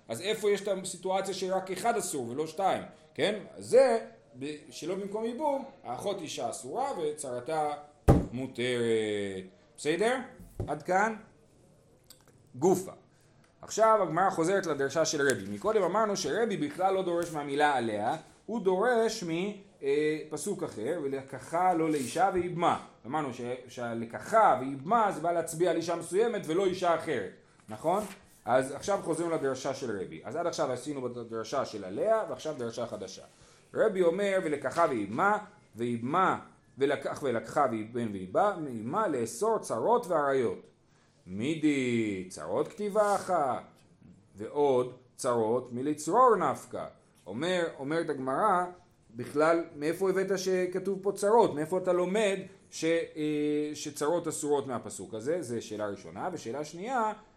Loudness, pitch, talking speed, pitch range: -30 LUFS, 160 Hz, 125 wpm, 130-190 Hz